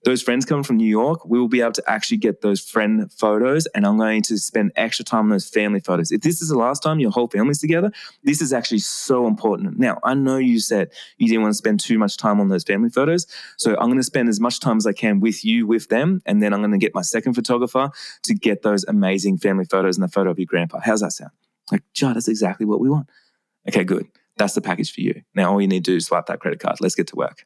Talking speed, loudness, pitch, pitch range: 280 wpm, -20 LUFS, 115 Hz, 105-145 Hz